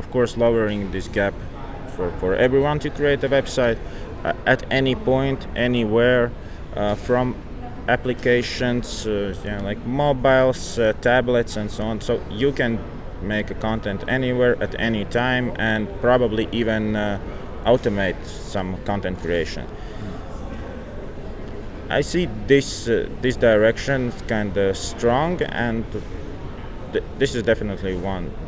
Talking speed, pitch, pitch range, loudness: 135 wpm, 110 Hz, 100-125 Hz, -22 LUFS